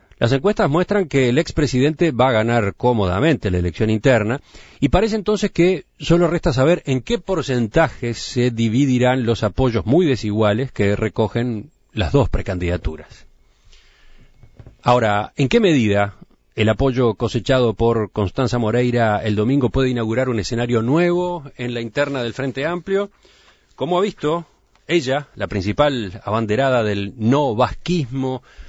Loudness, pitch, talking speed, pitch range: -19 LUFS, 125 Hz, 140 wpm, 110-145 Hz